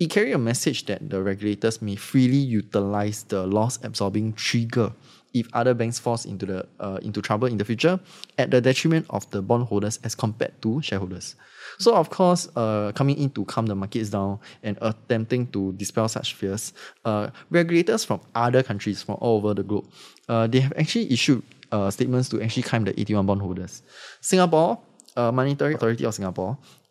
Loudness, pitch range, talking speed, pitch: -24 LUFS, 105-130 Hz, 180 wpm, 115 Hz